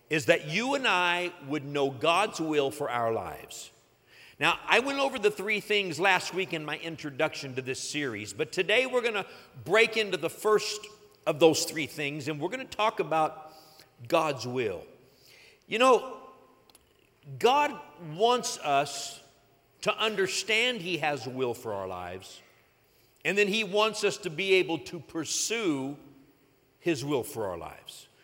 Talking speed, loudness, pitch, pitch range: 160 wpm, -28 LUFS, 160 Hz, 140-205 Hz